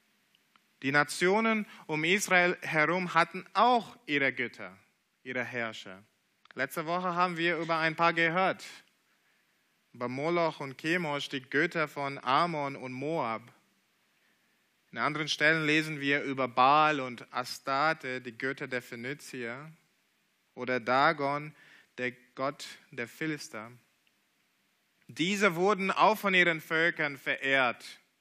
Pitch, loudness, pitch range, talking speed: 150 Hz, -29 LUFS, 130-170 Hz, 120 wpm